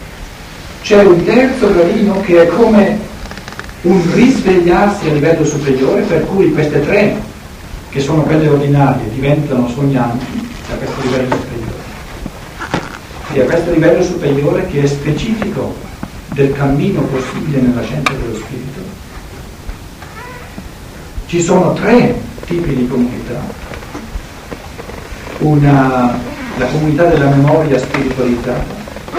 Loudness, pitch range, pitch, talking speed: -12 LUFS, 125-175 Hz, 145 Hz, 110 wpm